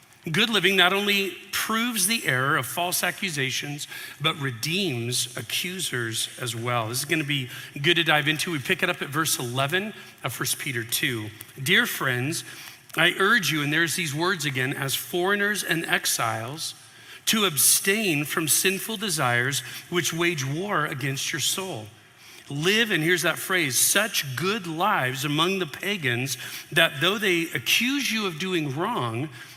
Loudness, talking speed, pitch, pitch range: -23 LUFS, 160 wpm, 160 Hz, 130-185 Hz